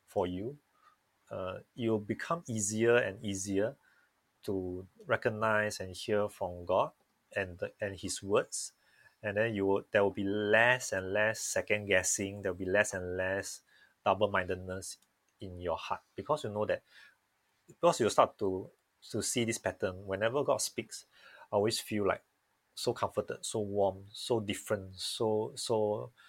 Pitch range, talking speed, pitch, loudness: 95-110 Hz, 155 wpm, 100 Hz, -33 LUFS